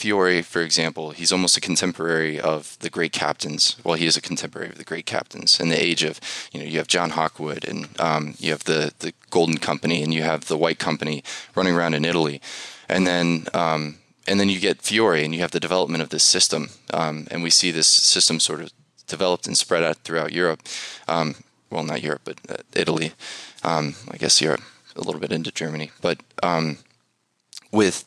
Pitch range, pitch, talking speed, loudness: 75-85 Hz, 80 Hz, 205 wpm, -21 LUFS